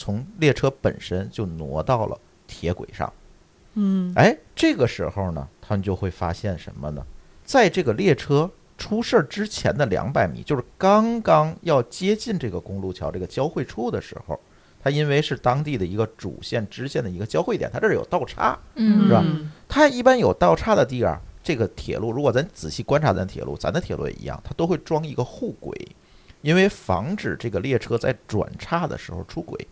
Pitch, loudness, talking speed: 135 Hz, -23 LUFS, 290 characters per minute